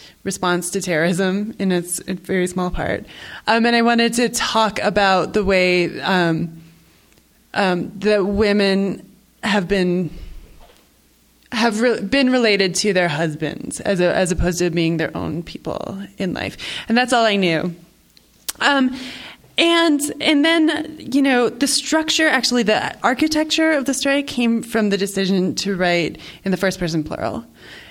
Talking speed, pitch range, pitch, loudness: 155 wpm, 180-245 Hz, 200 Hz, -18 LUFS